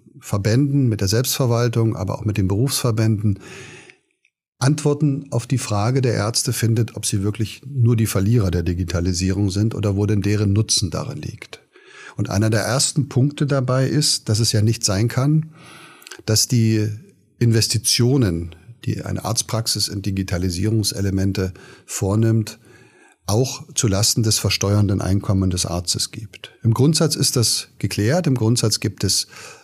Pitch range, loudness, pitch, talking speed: 100-125 Hz, -19 LUFS, 110 Hz, 145 wpm